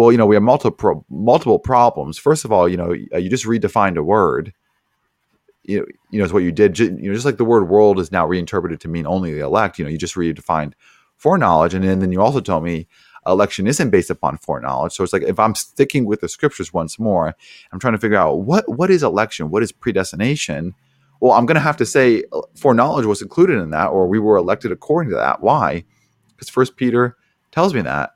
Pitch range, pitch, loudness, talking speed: 90-125 Hz, 105 Hz, -17 LUFS, 230 wpm